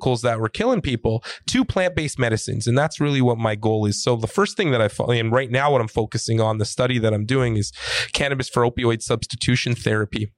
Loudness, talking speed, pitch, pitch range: -21 LUFS, 225 wpm, 120 Hz, 110-130 Hz